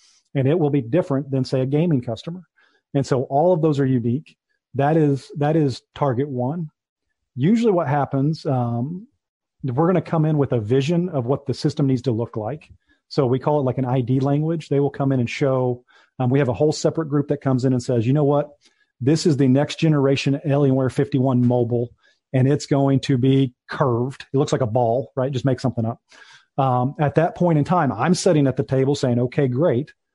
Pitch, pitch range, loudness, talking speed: 140 Hz, 130-150 Hz, -20 LUFS, 220 wpm